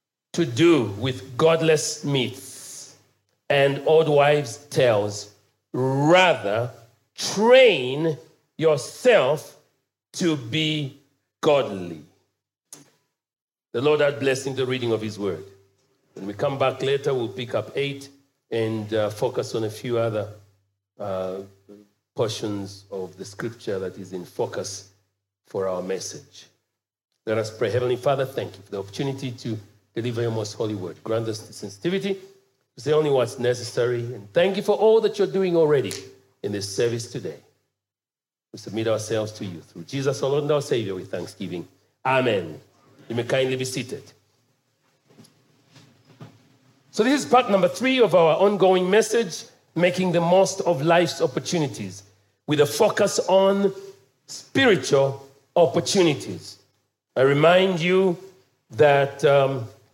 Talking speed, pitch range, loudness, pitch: 140 wpm, 110-155 Hz, -22 LUFS, 135 Hz